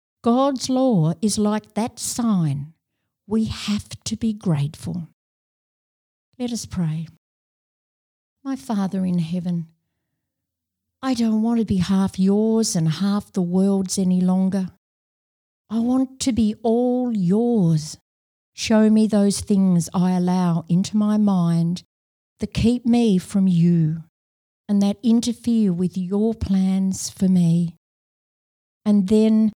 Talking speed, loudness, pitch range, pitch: 125 wpm, -21 LUFS, 175-220 Hz, 195 Hz